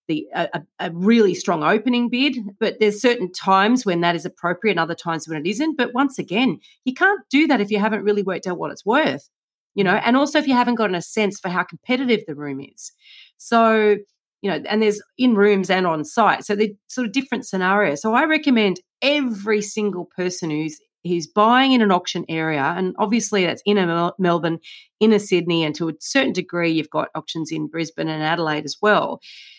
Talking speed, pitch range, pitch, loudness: 215 wpm, 175-235 Hz, 205 Hz, -20 LUFS